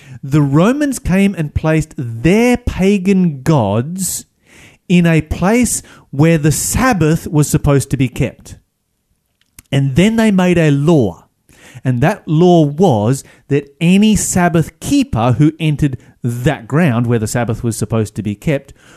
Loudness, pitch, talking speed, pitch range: -14 LUFS, 155 Hz, 140 wpm, 135-175 Hz